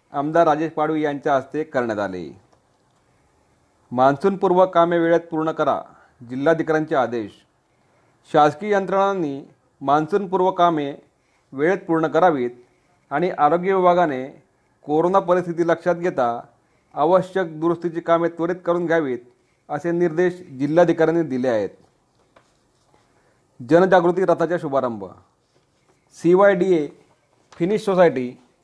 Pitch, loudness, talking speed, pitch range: 165 Hz, -20 LUFS, 100 wpm, 140-175 Hz